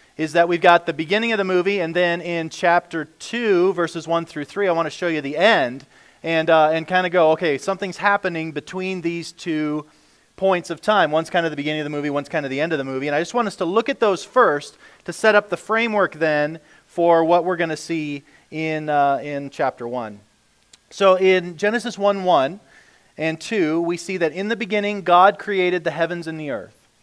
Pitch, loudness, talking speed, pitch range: 170 Hz, -20 LUFS, 230 wpm, 155-185 Hz